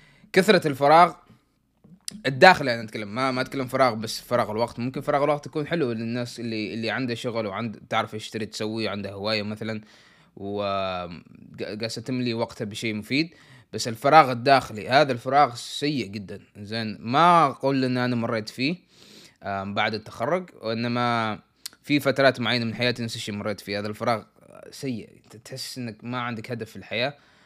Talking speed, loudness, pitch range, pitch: 150 wpm, -24 LUFS, 110-135 Hz, 120 Hz